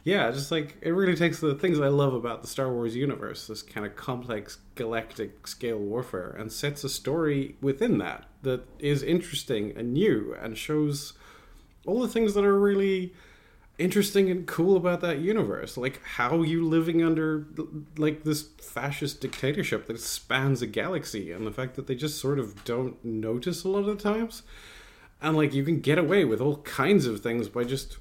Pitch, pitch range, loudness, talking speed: 145 Hz, 120-165 Hz, -28 LUFS, 190 wpm